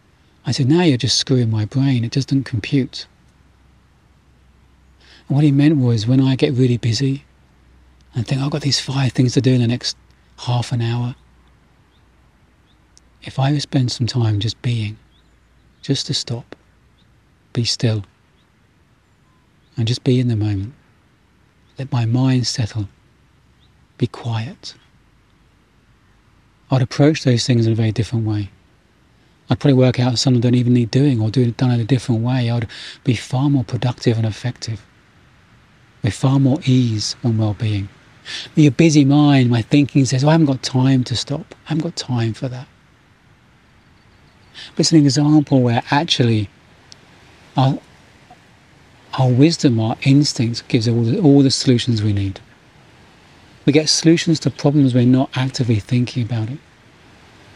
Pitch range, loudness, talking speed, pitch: 110-135 Hz, -17 LUFS, 160 wpm, 125 Hz